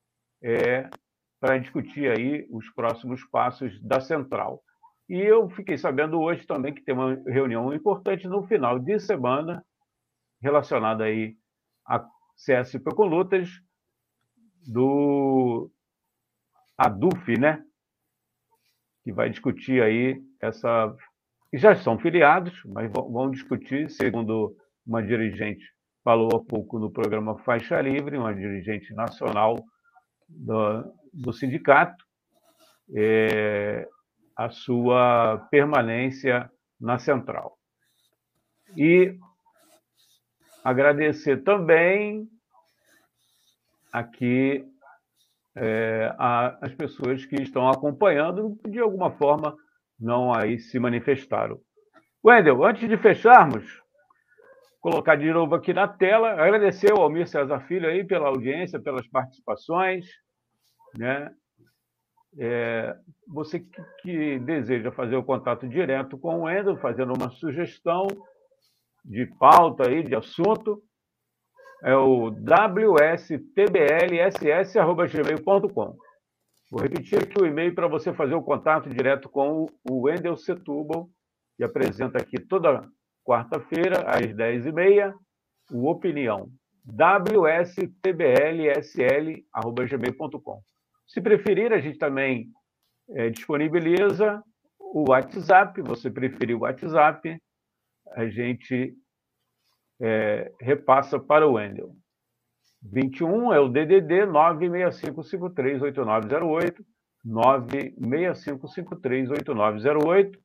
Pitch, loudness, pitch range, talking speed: 145 Hz, -23 LUFS, 125-185 Hz, 95 wpm